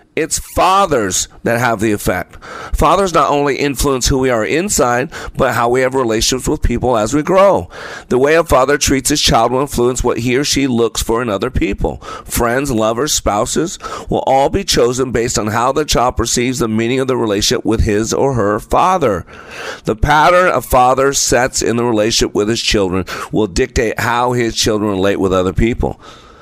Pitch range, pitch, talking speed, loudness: 115-135 Hz, 125 Hz, 195 wpm, -14 LUFS